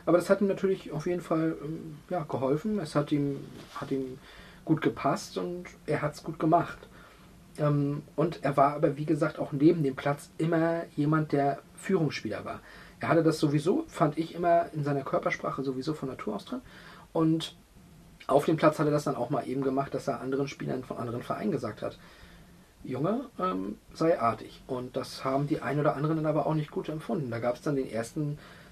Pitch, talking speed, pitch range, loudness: 150 Hz, 205 wpm, 140-165 Hz, -30 LUFS